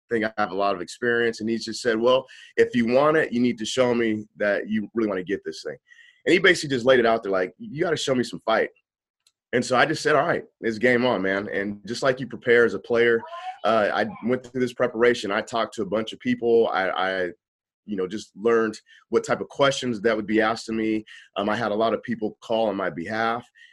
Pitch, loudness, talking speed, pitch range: 115 Hz, -23 LUFS, 265 wpm, 110-125 Hz